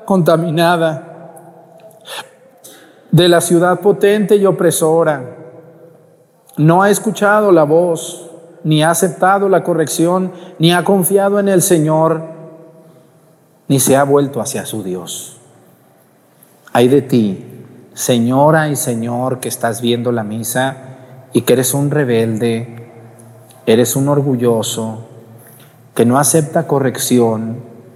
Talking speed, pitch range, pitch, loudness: 115 wpm, 125-170 Hz, 155 Hz, -13 LUFS